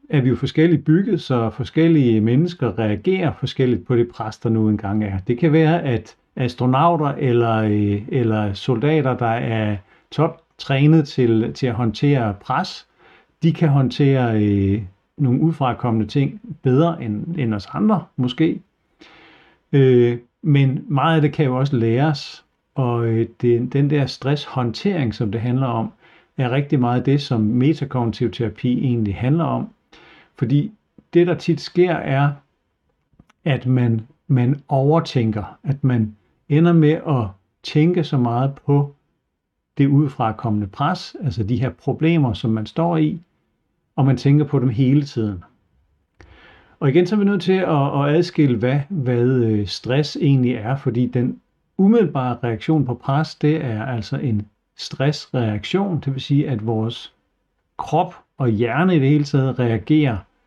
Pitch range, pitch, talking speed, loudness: 115-155 Hz, 130 Hz, 150 wpm, -19 LUFS